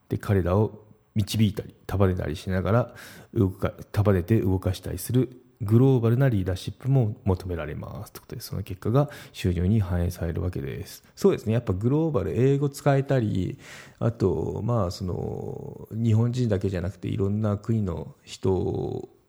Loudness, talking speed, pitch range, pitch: -26 LUFS, 315 characters per minute, 95-125 Hz, 110 Hz